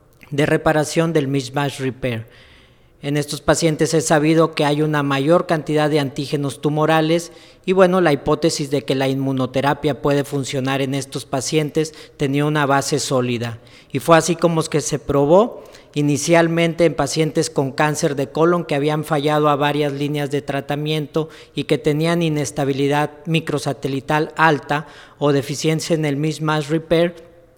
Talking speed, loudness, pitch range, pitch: 150 wpm, -19 LUFS, 140-160 Hz, 150 Hz